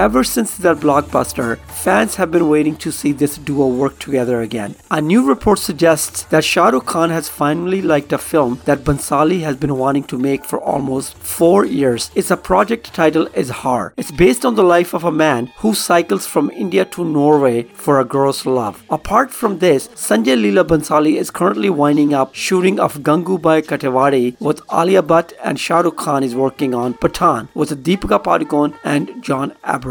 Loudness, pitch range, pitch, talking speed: -15 LUFS, 135-170 Hz, 150 Hz, 185 wpm